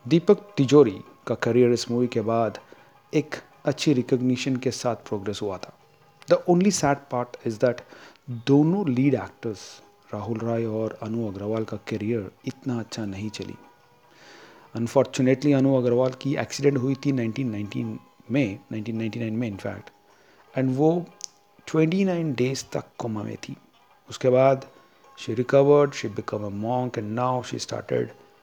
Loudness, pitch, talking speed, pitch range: -25 LUFS, 125 Hz, 140 wpm, 115-140 Hz